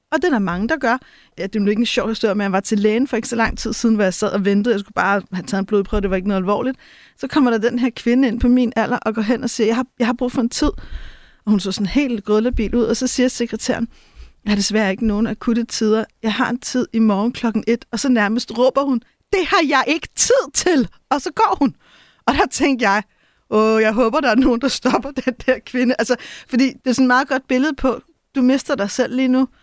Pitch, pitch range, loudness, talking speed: 240 Hz, 215-260 Hz, -18 LUFS, 280 wpm